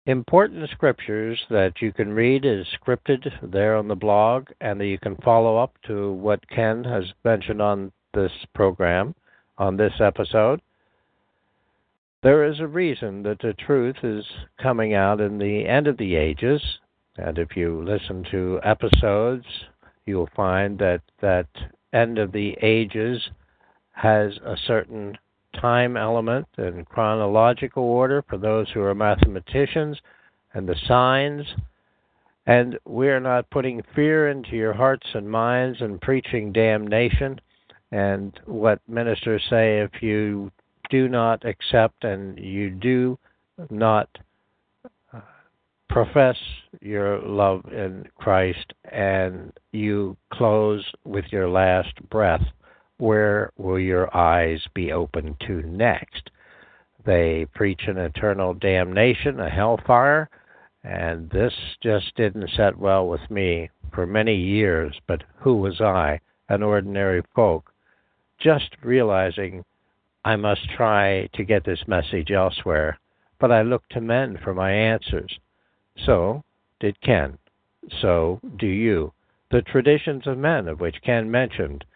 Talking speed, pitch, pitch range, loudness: 130 wpm, 105 Hz, 95-120 Hz, -22 LUFS